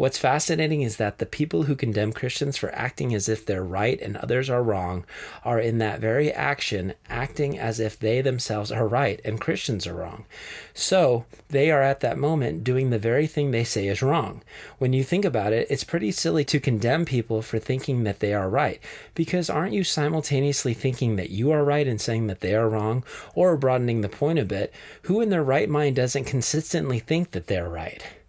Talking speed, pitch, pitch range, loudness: 210 wpm, 130 Hz, 110-145 Hz, -24 LUFS